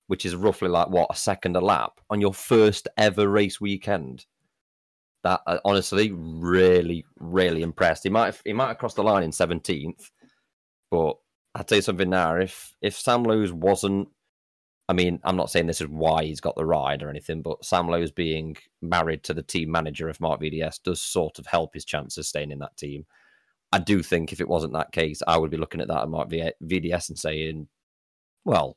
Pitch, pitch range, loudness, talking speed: 85 Hz, 80-95 Hz, -25 LUFS, 205 wpm